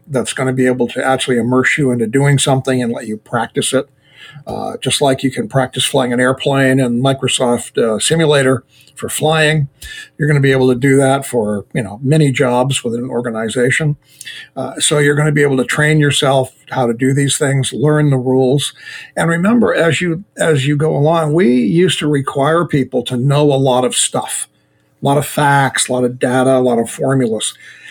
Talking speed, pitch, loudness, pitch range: 210 wpm, 135 Hz, -14 LUFS, 125-150 Hz